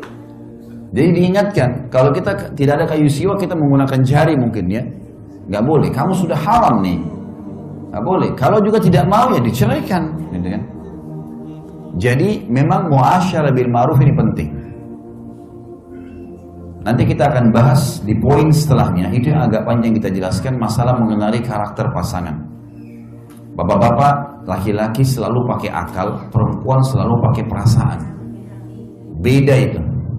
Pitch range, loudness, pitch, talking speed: 100-140 Hz, -15 LUFS, 120 Hz, 125 wpm